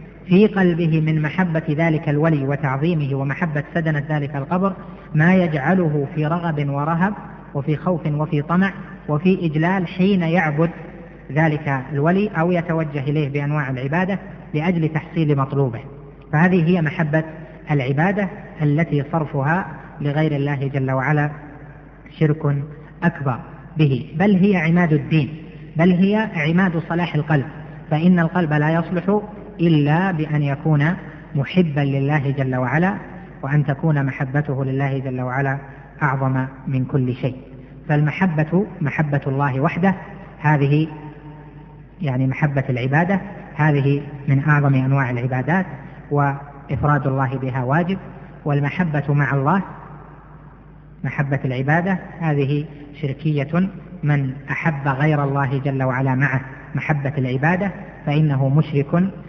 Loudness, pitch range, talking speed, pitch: -20 LUFS, 140-170 Hz, 115 wpm, 150 Hz